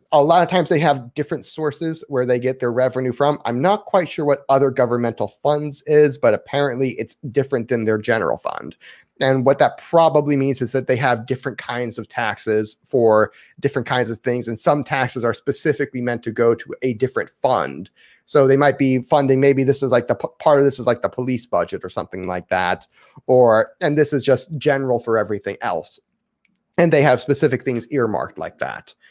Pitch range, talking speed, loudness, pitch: 120-145 Hz, 210 wpm, -19 LUFS, 130 Hz